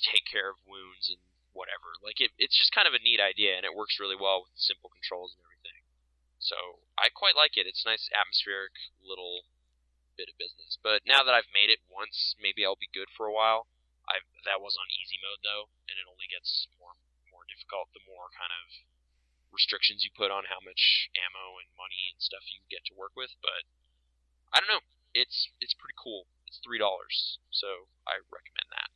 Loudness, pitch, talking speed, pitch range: -28 LUFS, 90 Hz, 210 wpm, 60-95 Hz